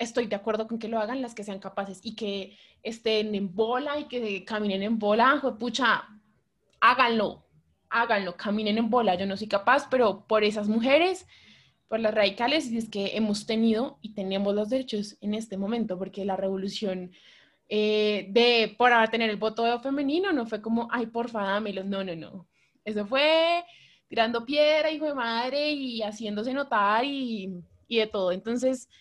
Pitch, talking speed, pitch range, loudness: 220 Hz, 175 wpm, 205-245 Hz, -26 LUFS